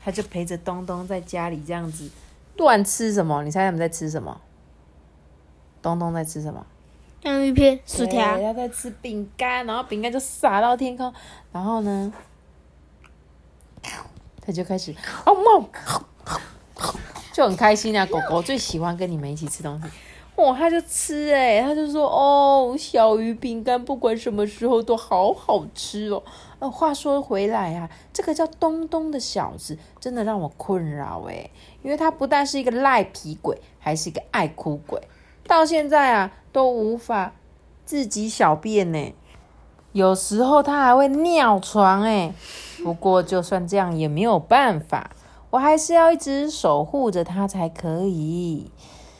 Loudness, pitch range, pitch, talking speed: -21 LUFS, 165-265 Hz, 205 Hz, 225 characters per minute